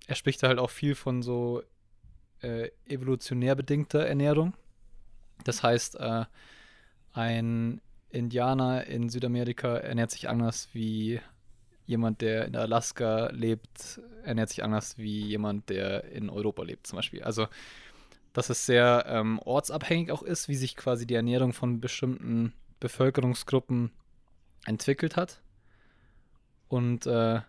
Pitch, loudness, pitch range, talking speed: 120 Hz, -30 LUFS, 110-130 Hz, 130 wpm